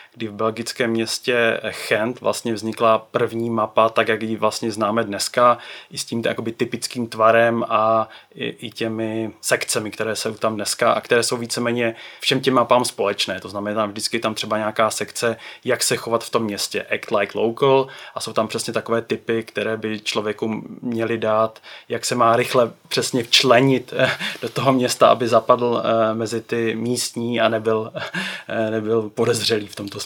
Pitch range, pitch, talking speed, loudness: 110-115 Hz, 115 Hz, 175 wpm, -20 LUFS